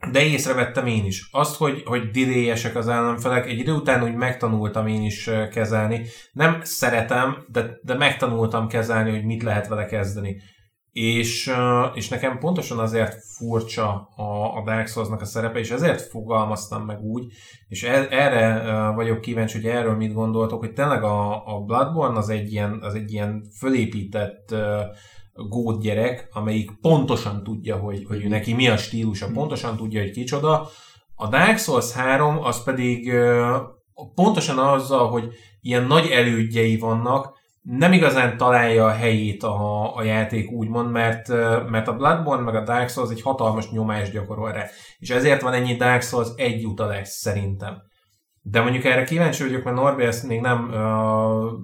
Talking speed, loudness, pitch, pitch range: 160 wpm, -22 LUFS, 115 Hz, 110-125 Hz